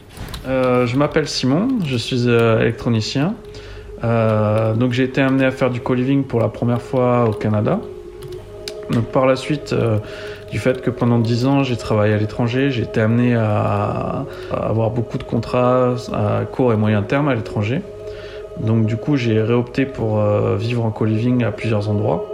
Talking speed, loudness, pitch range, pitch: 180 wpm, -18 LUFS, 110-135 Hz, 120 Hz